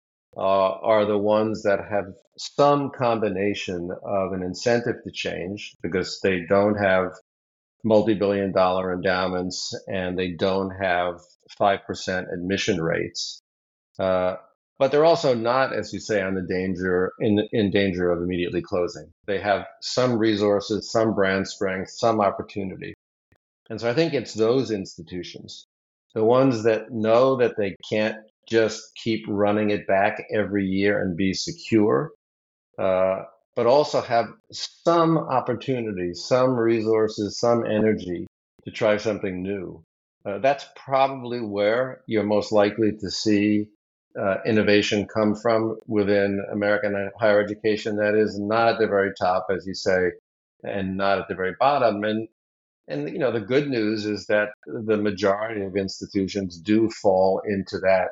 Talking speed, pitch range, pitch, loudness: 145 wpm, 95-110 Hz, 105 Hz, -23 LUFS